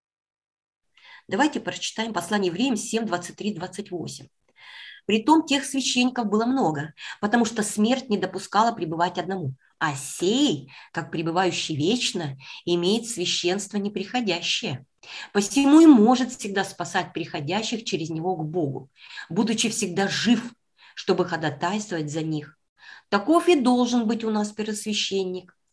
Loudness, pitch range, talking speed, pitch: -24 LUFS, 175-230 Hz, 120 wpm, 200 Hz